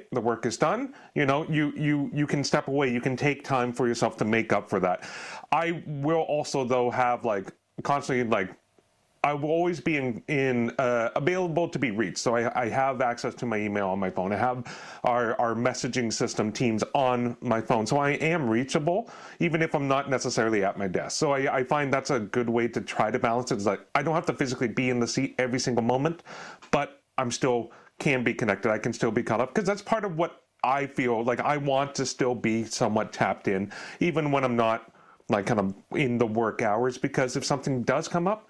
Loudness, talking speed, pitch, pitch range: -27 LUFS, 230 wpm, 130 Hz, 120-145 Hz